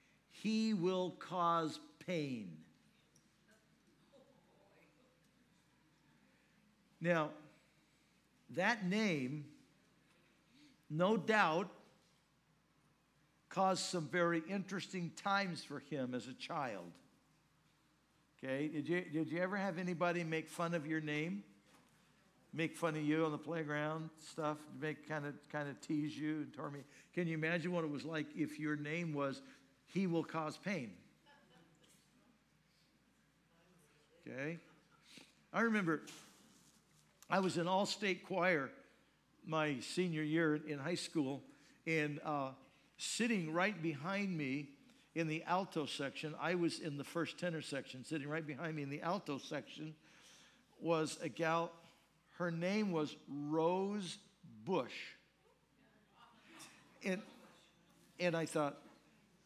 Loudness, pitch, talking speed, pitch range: -40 LUFS, 165 Hz, 115 wpm, 150-180 Hz